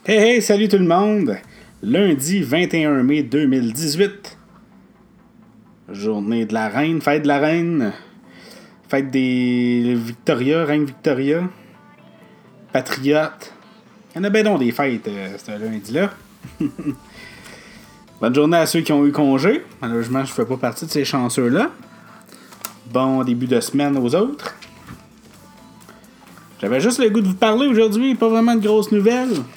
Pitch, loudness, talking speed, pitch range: 150 Hz, -18 LUFS, 140 wpm, 130-210 Hz